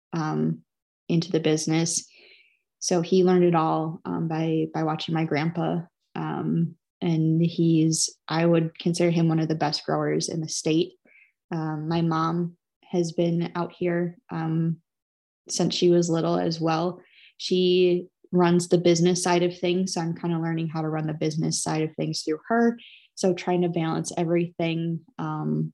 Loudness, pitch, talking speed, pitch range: -25 LUFS, 165 Hz, 170 wpm, 160-175 Hz